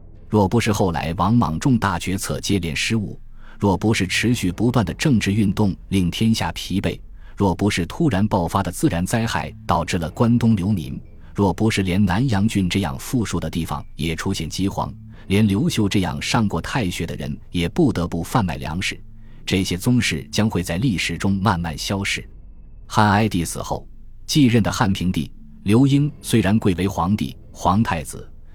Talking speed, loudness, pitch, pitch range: 265 characters per minute, -21 LUFS, 100 Hz, 85-110 Hz